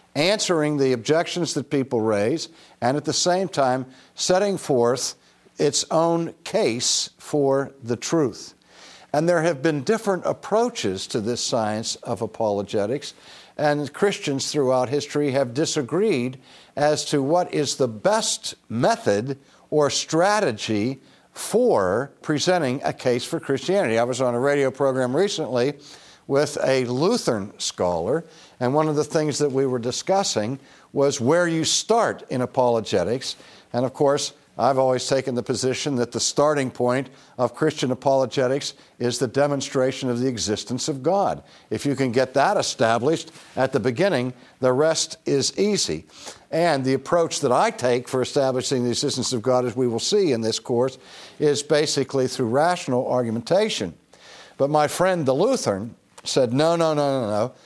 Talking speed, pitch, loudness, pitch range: 155 wpm, 135 Hz, -22 LUFS, 125-150 Hz